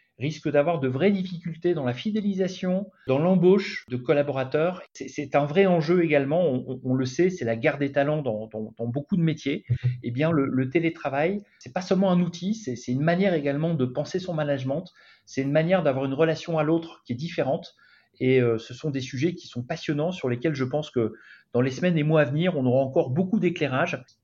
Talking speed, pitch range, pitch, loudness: 225 wpm, 130-175 Hz, 150 Hz, -25 LUFS